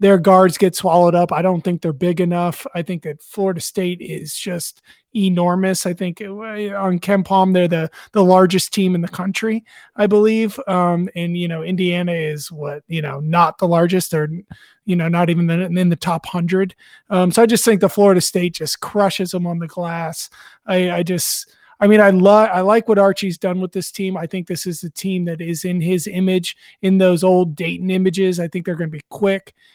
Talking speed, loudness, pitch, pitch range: 220 wpm, -17 LUFS, 180 Hz, 175-195 Hz